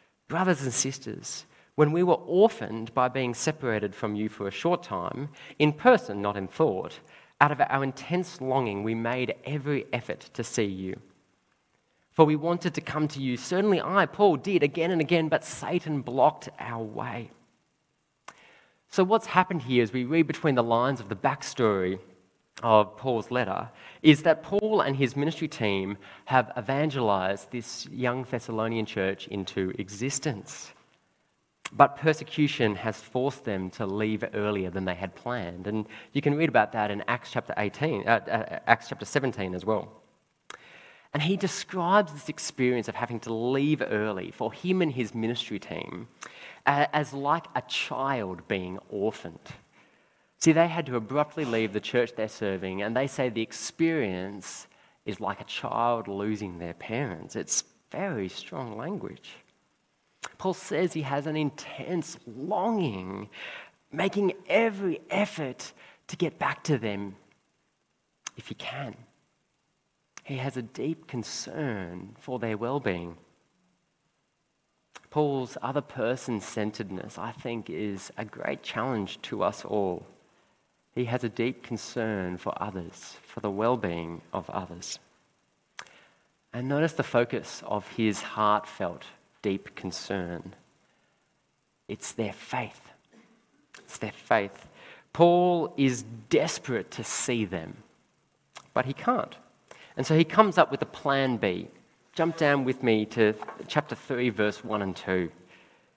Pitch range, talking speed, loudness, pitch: 105-150 Hz, 145 wpm, -28 LUFS, 125 Hz